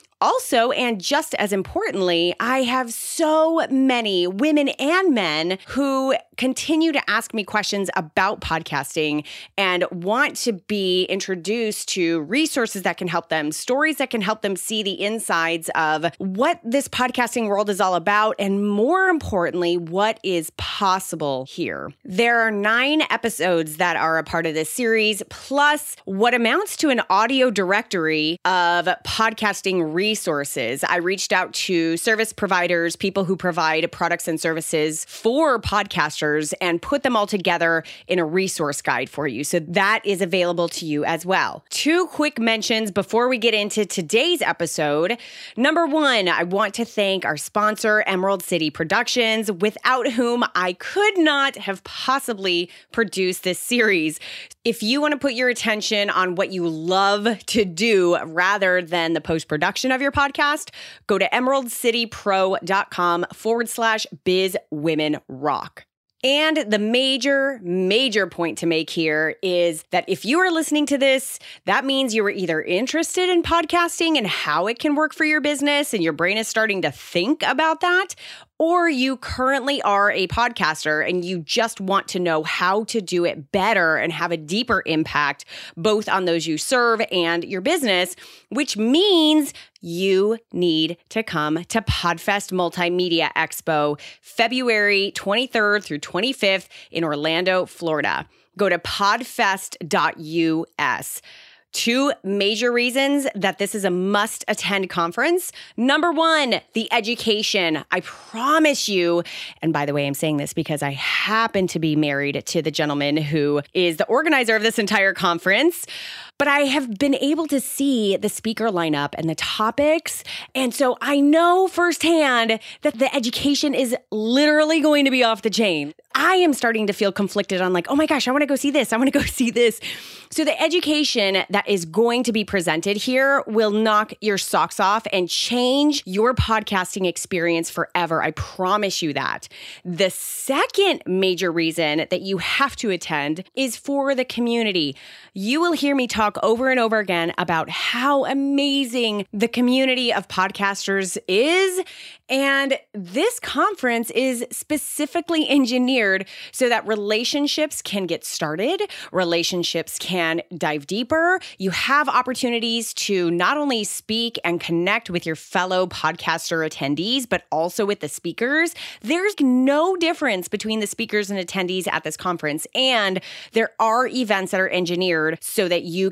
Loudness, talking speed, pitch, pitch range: -20 LUFS, 155 wpm, 210 Hz, 175-260 Hz